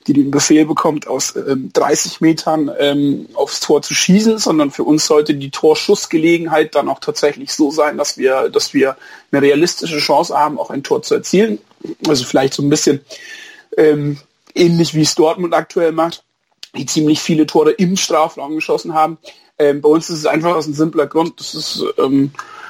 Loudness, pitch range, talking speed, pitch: -14 LUFS, 150-200 Hz, 185 wpm, 160 Hz